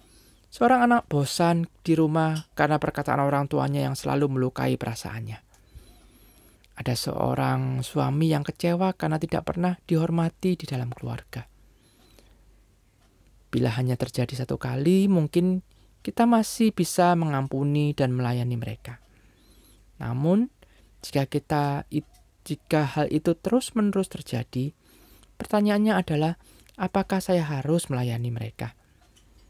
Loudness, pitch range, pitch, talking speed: -25 LUFS, 125-175 Hz, 150 Hz, 110 wpm